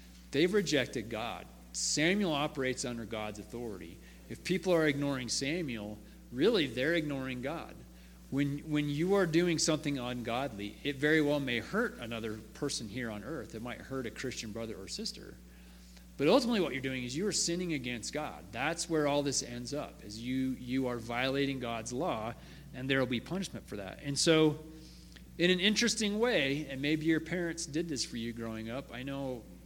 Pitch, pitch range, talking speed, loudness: 135 Hz, 115-155 Hz, 185 wpm, -33 LUFS